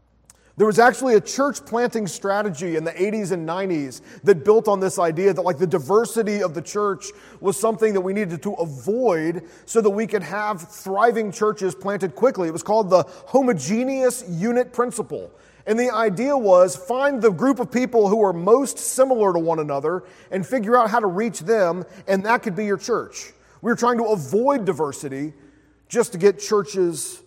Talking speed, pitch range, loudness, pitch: 190 wpm, 185-235 Hz, -21 LUFS, 210 Hz